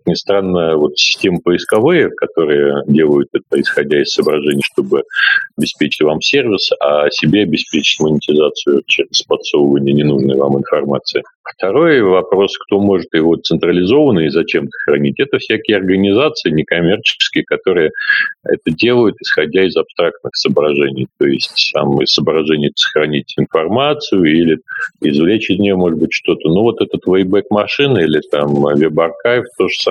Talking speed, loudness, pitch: 135 wpm, -13 LUFS, 95 Hz